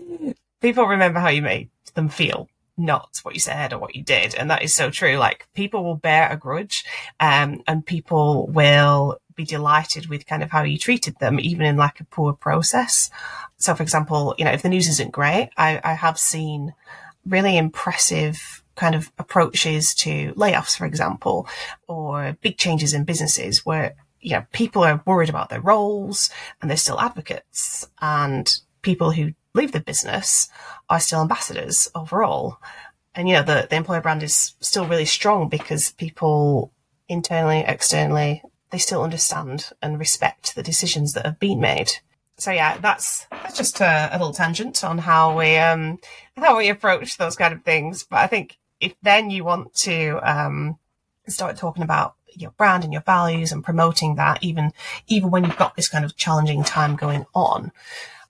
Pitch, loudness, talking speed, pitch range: 160 Hz, -19 LUFS, 180 wpm, 150-180 Hz